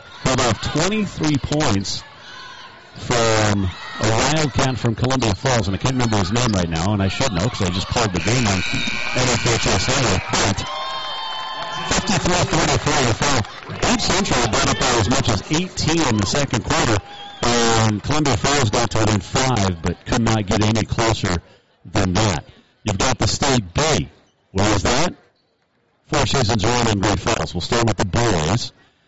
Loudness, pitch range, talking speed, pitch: -19 LUFS, 105-140 Hz, 165 wpm, 120 Hz